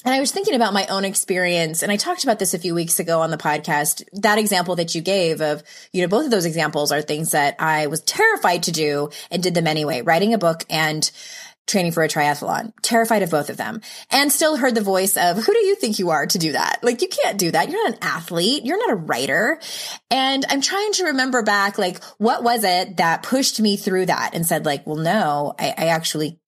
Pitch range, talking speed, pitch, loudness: 160-230 Hz, 245 wpm, 185 Hz, -19 LUFS